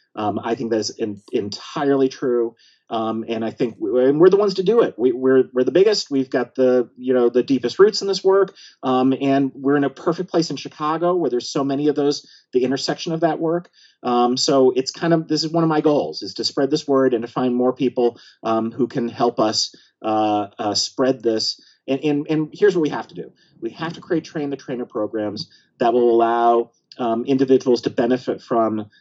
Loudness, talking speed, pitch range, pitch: -20 LUFS, 225 wpm, 120-155 Hz, 130 Hz